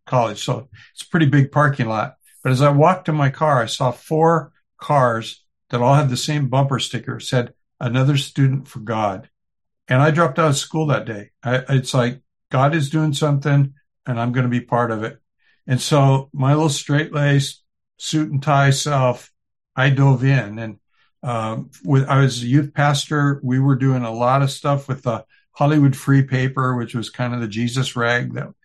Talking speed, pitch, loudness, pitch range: 200 wpm, 135 Hz, -19 LUFS, 120-145 Hz